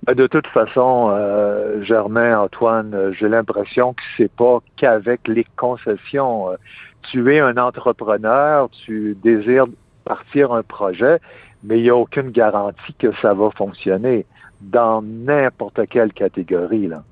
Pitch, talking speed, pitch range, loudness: 115 Hz, 135 wpm, 105-125 Hz, -17 LUFS